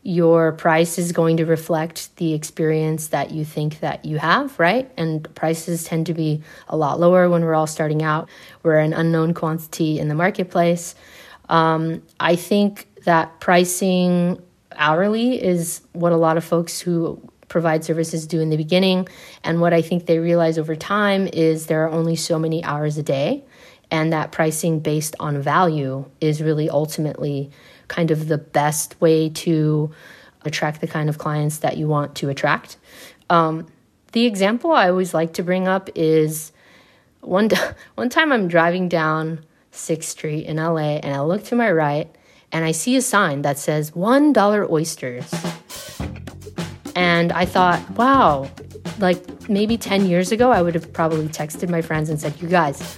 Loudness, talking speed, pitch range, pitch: -19 LUFS, 170 wpm, 155-180 Hz, 165 Hz